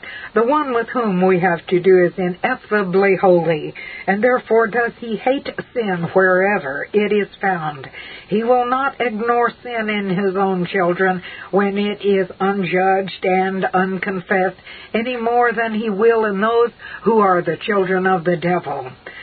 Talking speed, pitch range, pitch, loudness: 155 wpm, 185-230 Hz, 195 Hz, -18 LUFS